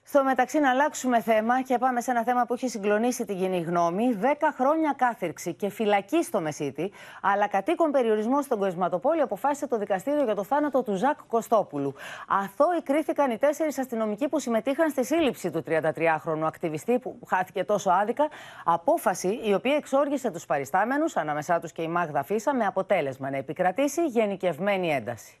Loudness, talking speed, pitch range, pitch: -26 LUFS, 170 wpm, 185-280 Hz, 225 Hz